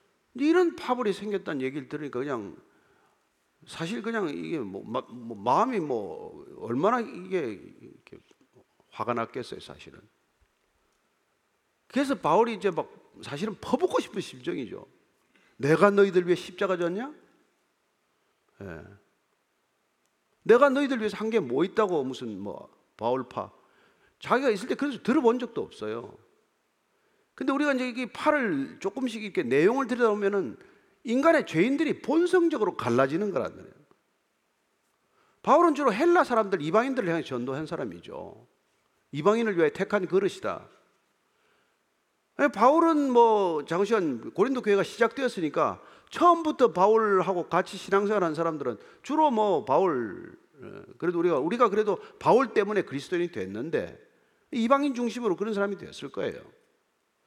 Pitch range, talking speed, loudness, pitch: 195-285 Hz, 300 characters per minute, -26 LUFS, 230 Hz